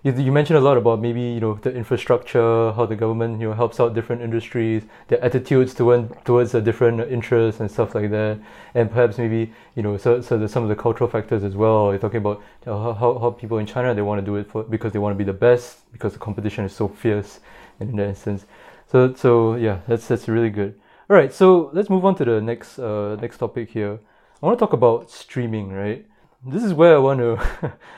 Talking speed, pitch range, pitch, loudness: 230 wpm, 105-120 Hz, 115 Hz, -20 LUFS